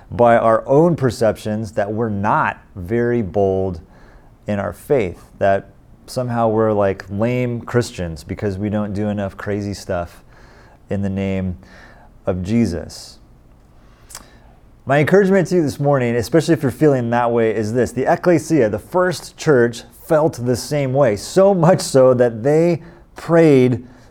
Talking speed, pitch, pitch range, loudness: 145 wpm, 120 Hz, 100-135 Hz, -17 LUFS